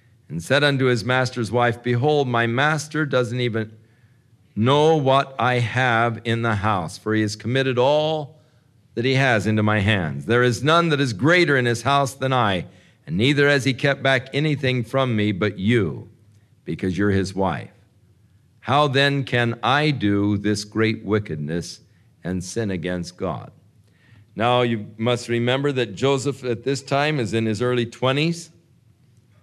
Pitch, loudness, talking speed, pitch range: 120 Hz, -21 LUFS, 165 wpm, 110-135 Hz